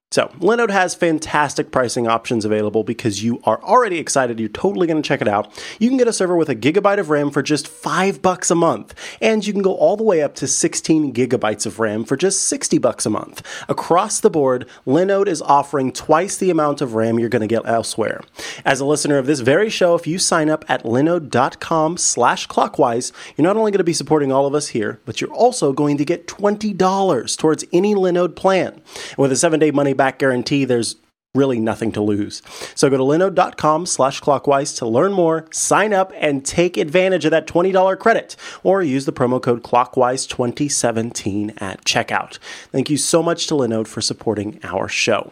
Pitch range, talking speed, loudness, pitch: 125-175 Hz, 200 wpm, -17 LUFS, 145 Hz